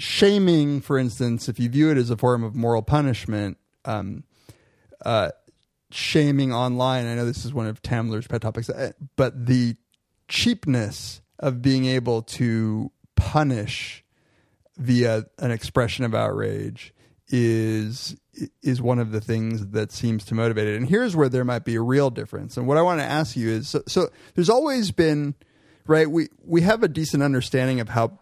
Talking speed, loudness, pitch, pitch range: 170 wpm, -23 LUFS, 125 Hz, 115-145 Hz